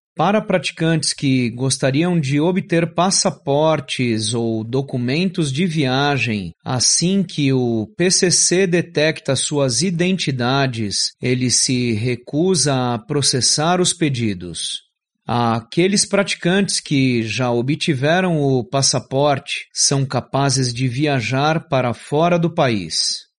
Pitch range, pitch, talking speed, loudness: 125-170 Hz, 140 Hz, 105 wpm, -17 LUFS